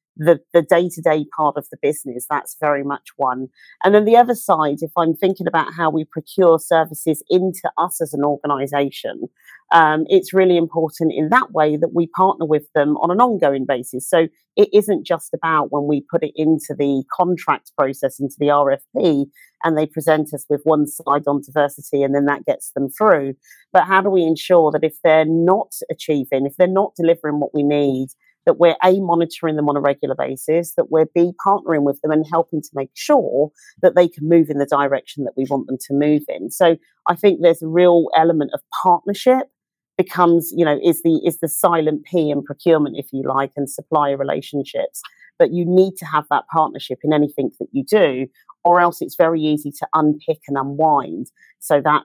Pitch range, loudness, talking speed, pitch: 145-170 Hz, -17 LUFS, 205 wpm, 155 Hz